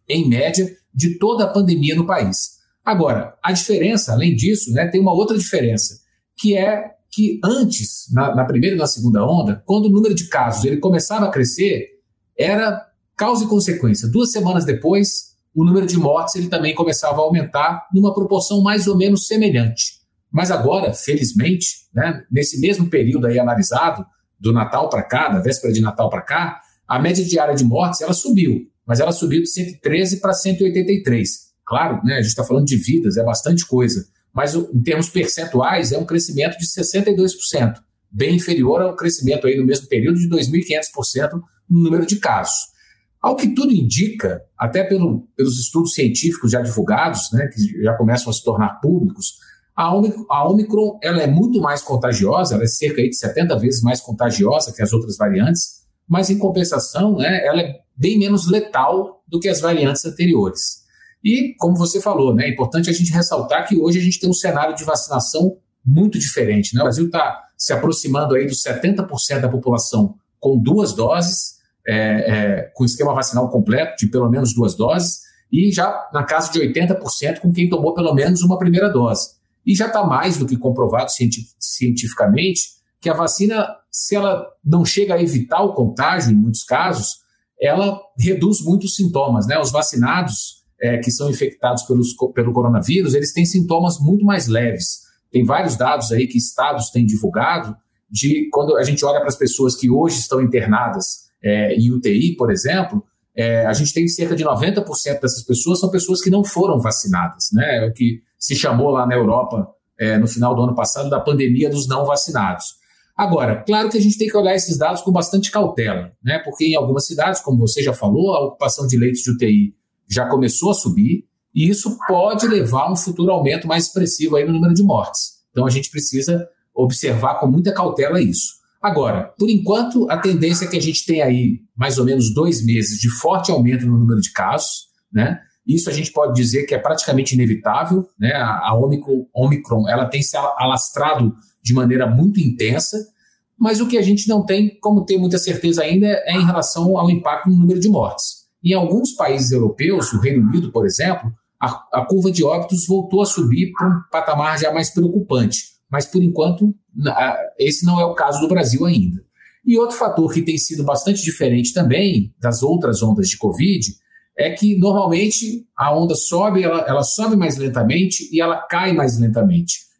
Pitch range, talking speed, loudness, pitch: 125-190 Hz, 190 wpm, -16 LUFS, 160 Hz